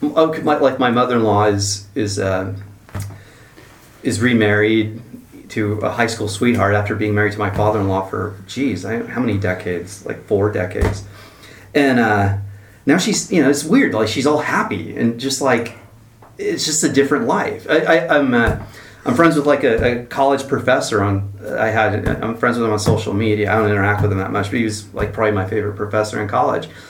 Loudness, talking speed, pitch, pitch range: -17 LUFS, 200 wpm, 105 Hz, 105-120 Hz